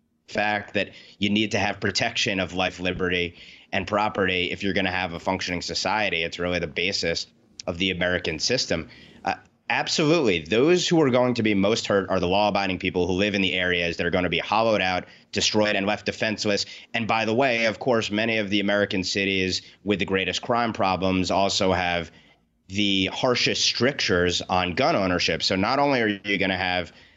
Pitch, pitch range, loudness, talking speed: 95 Hz, 90-105 Hz, -23 LUFS, 200 wpm